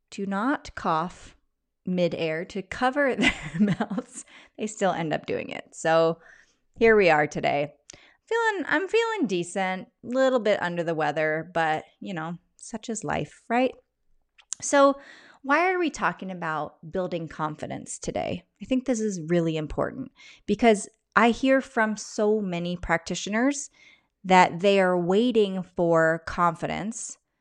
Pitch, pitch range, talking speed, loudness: 200 Hz, 170-255 Hz, 140 wpm, -25 LUFS